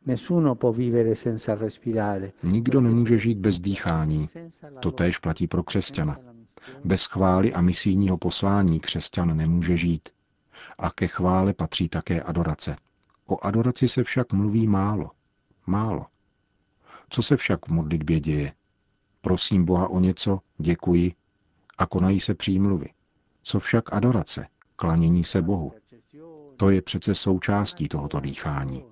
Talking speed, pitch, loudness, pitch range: 120 wpm, 95 Hz, -24 LUFS, 85-110 Hz